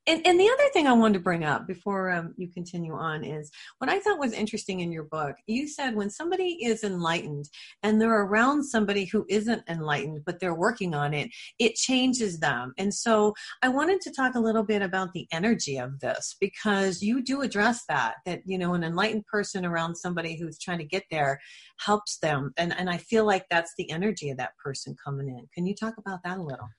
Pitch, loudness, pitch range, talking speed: 190 Hz, -27 LUFS, 165-225 Hz, 220 wpm